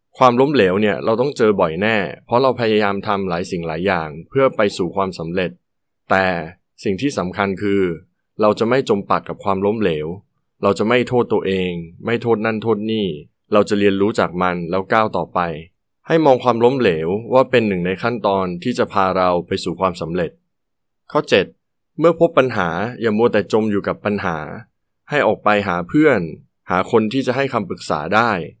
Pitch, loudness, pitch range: 105 Hz, -18 LUFS, 95-120 Hz